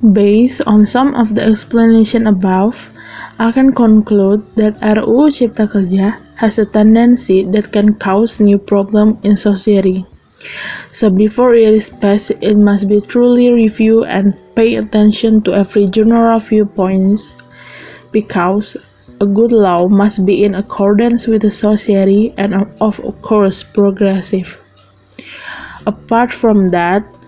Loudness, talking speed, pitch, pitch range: -11 LUFS, 130 wpm, 210 Hz, 200-225 Hz